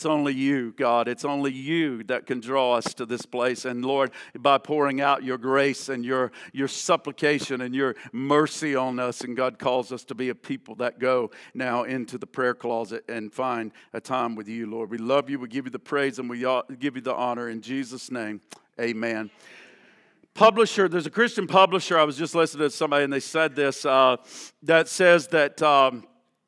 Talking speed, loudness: 205 wpm, -24 LUFS